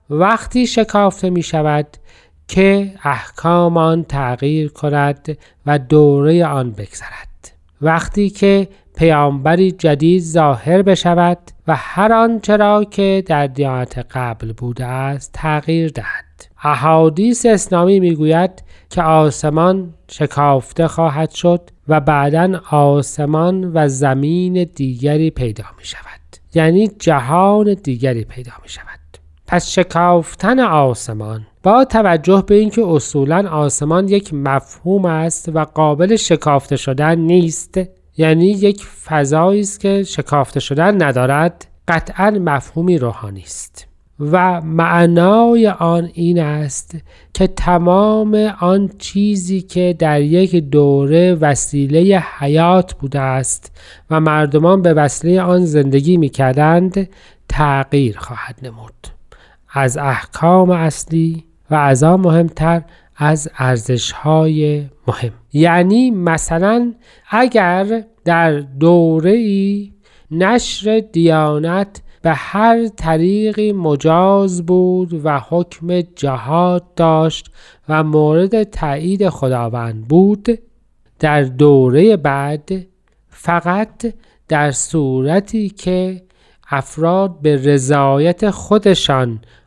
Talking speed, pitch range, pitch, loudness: 105 wpm, 145-185 Hz, 165 Hz, -14 LUFS